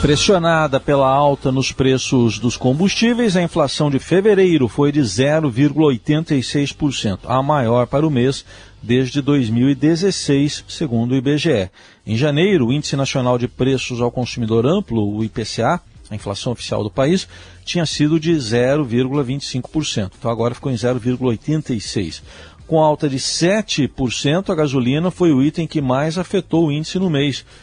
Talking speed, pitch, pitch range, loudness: 145 wpm, 135 Hz, 120-155 Hz, -17 LUFS